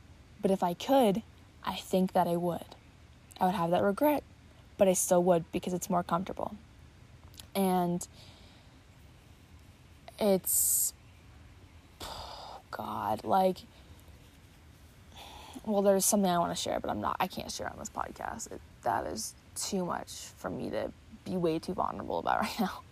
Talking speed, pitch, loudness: 150 wpm, 175 Hz, -31 LUFS